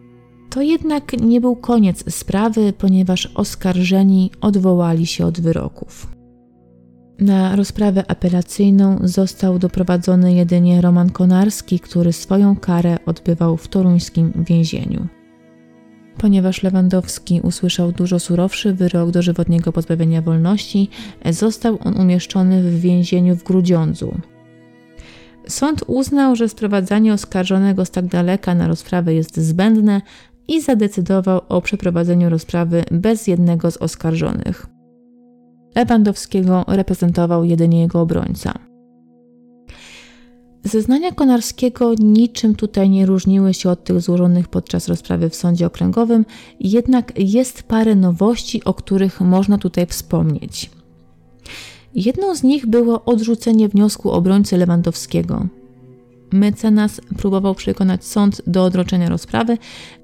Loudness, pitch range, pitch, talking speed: -16 LUFS, 170-205 Hz, 185 Hz, 110 wpm